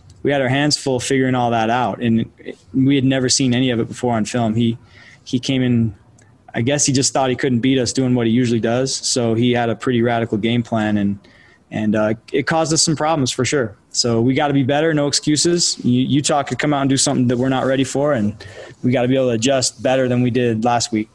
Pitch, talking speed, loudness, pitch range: 125 Hz, 260 wpm, -17 LUFS, 115-135 Hz